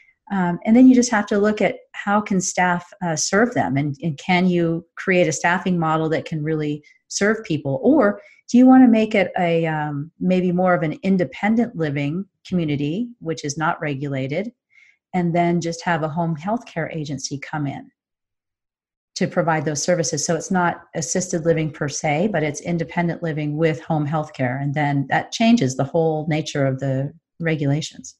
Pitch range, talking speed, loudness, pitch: 155-185 Hz, 185 wpm, -20 LUFS, 165 Hz